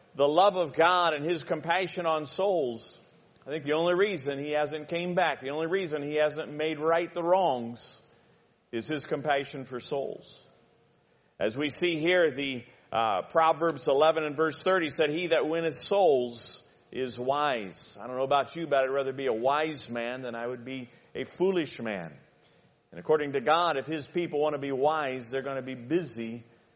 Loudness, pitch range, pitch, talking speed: -28 LUFS, 130-165 Hz, 150 Hz, 190 wpm